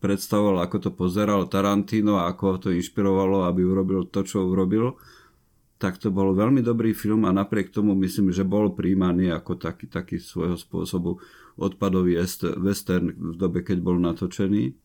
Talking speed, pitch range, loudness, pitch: 165 wpm, 90-100 Hz, -24 LUFS, 95 Hz